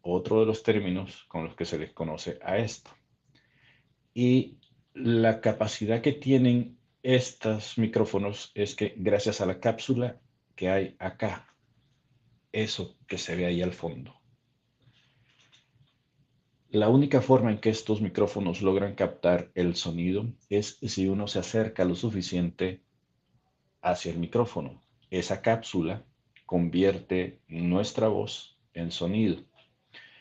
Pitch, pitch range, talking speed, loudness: 110 Hz, 95-125 Hz, 125 wpm, -28 LUFS